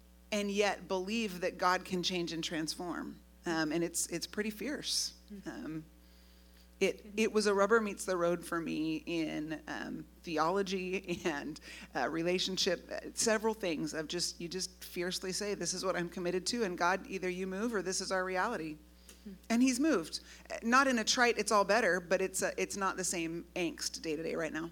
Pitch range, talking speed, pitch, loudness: 170-210 Hz, 185 wpm, 185 Hz, -34 LUFS